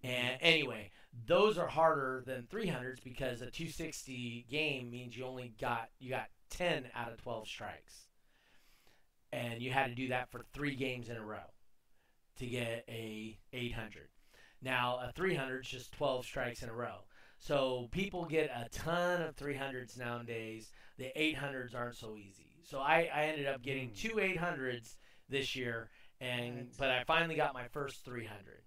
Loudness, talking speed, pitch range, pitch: -38 LUFS, 165 wpm, 120-145 Hz, 125 Hz